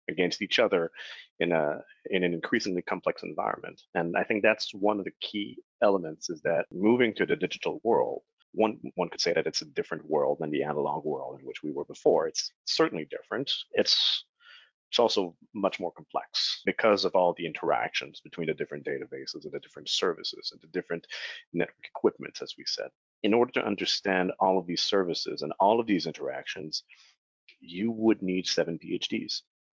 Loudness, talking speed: -29 LUFS, 185 wpm